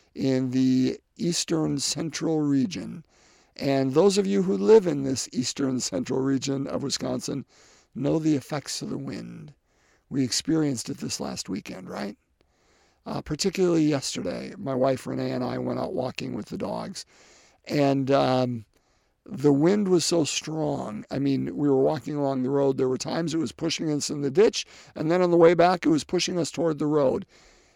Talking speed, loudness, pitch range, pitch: 180 wpm, -25 LUFS, 135-165 Hz, 145 Hz